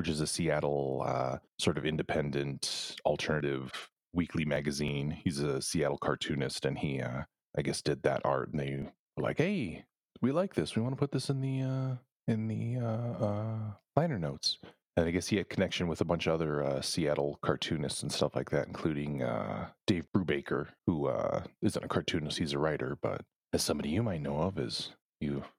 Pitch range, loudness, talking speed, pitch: 70-110 Hz, -33 LUFS, 195 wpm, 80 Hz